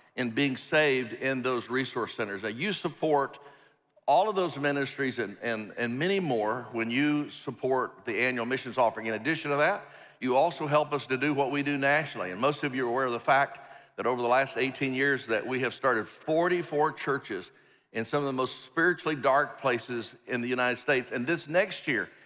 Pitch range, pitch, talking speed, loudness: 125-150 Hz, 140 Hz, 210 wpm, -29 LUFS